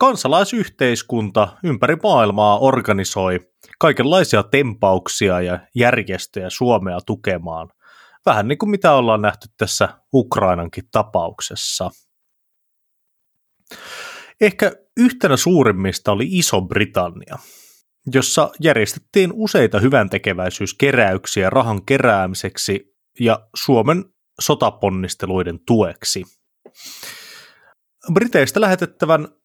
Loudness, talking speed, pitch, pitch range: -17 LUFS, 75 wpm, 120 Hz, 100-165 Hz